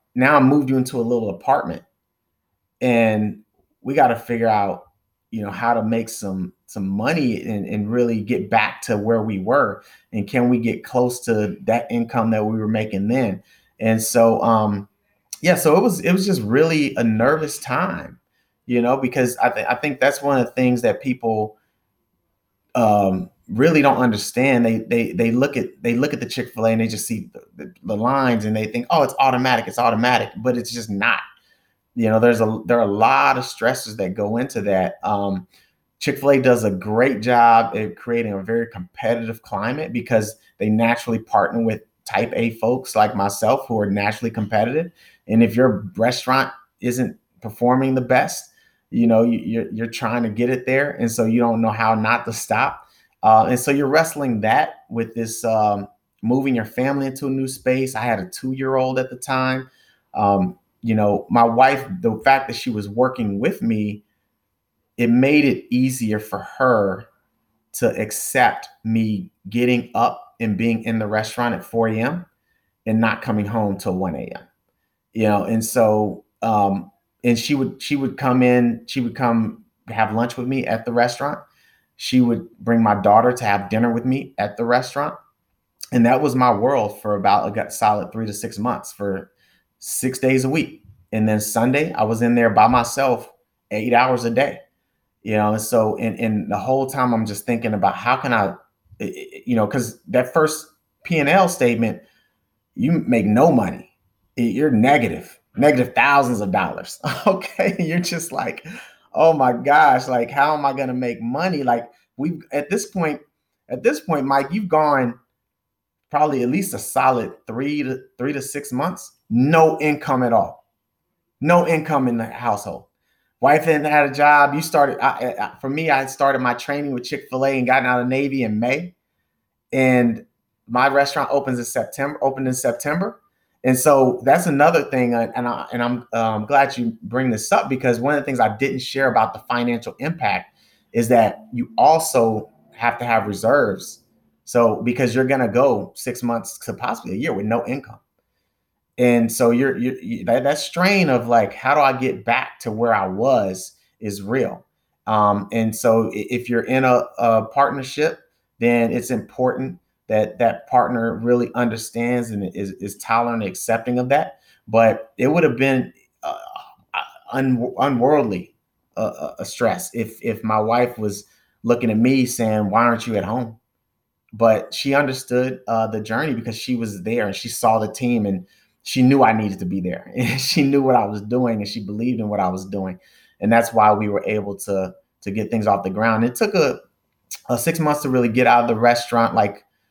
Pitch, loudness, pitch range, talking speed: 120 Hz, -19 LUFS, 110-130 Hz, 190 wpm